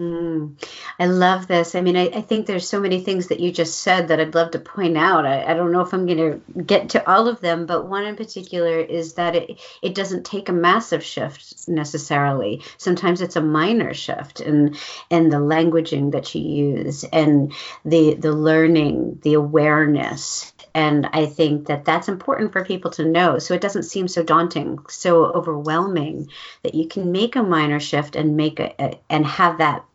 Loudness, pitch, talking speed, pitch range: -19 LUFS, 165 Hz, 200 wpm, 155-180 Hz